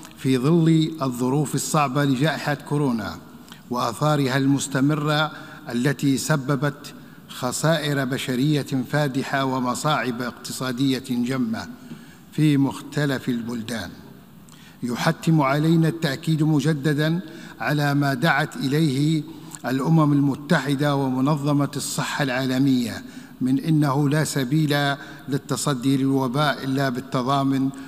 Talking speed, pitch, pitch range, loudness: 85 wpm, 145 Hz, 135-155 Hz, -22 LUFS